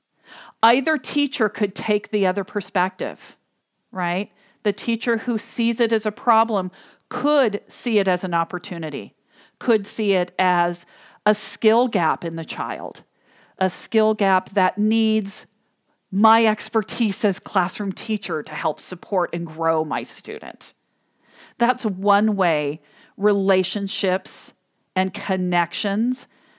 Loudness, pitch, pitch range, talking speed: -21 LUFS, 205 Hz, 185-225 Hz, 125 wpm